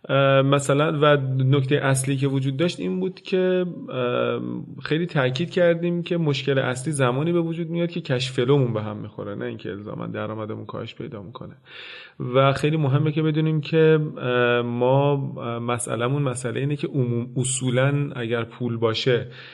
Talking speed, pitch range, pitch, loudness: 145 wpm, 125-155 Hz, 135 Hz, -23 LUFS